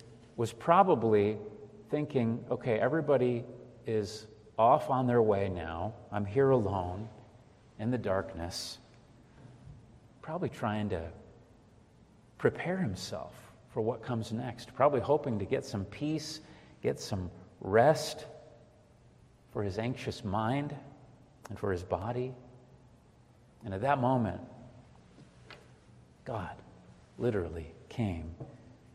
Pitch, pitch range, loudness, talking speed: 115 Hz, 105-125 Hz, -32 LUFS, 105 wpm